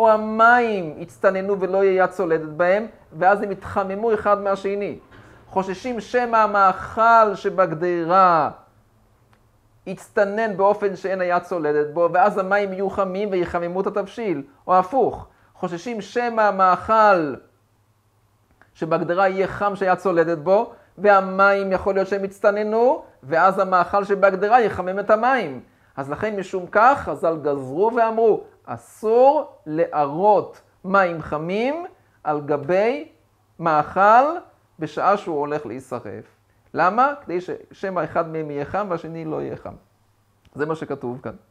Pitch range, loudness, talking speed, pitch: 155-205 Hz, -20 LUFS, 125 wpm, 190 Hz